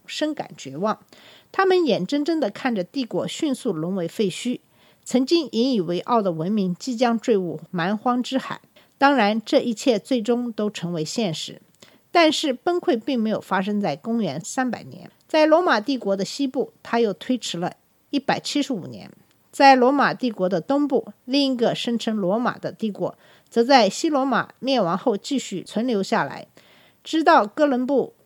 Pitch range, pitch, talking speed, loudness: 200-270 Hz, 240 Hz, 255 characters per minute, -22 LUFS